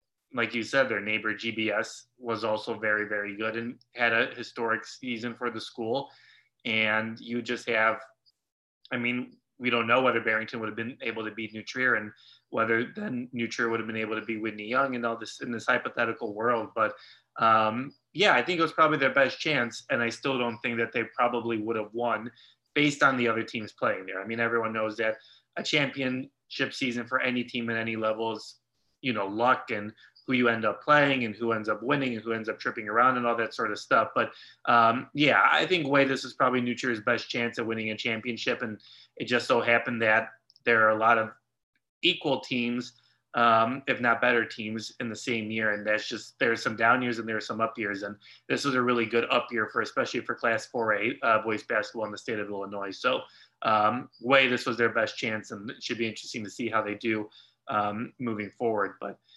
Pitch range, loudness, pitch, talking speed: 110-125 Hz, -27 LUFS, 115 Hz, 220 wpm